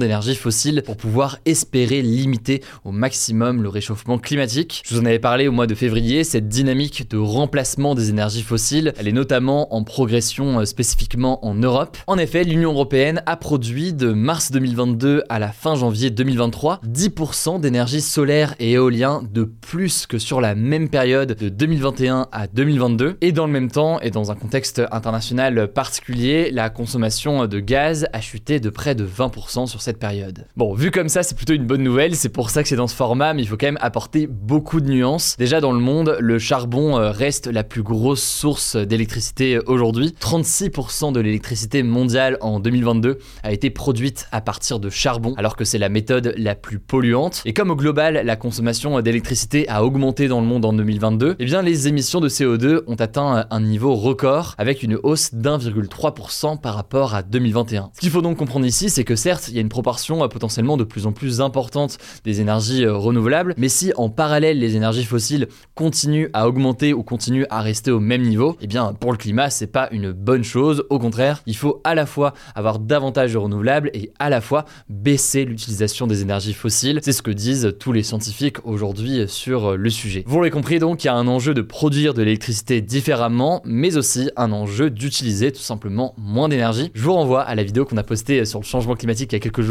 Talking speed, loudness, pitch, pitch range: 205 wpm, -19 LUFS, 125 Hz, 115-140 Hz